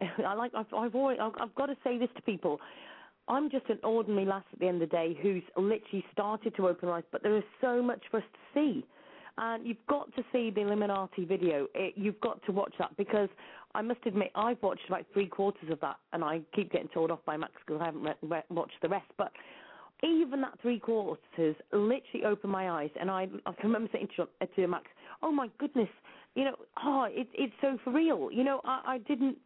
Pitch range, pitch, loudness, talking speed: 185-250 Hz, 215 Hz, -33 LUFS, 230 wpm